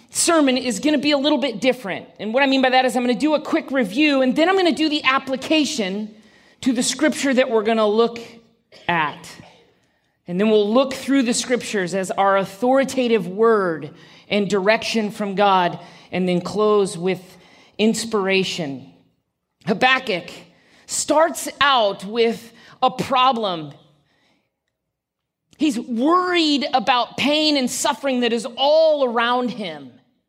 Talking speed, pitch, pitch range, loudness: 155 wpm, 240 Hz, 205-275 Hz, -19 LUFS